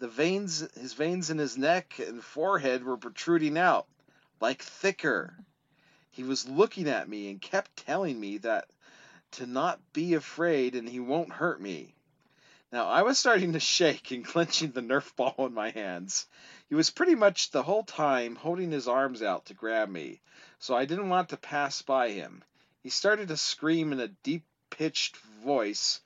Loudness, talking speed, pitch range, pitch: -29 LUFS, 180 wpm, 125-175 Hz, 150 Hz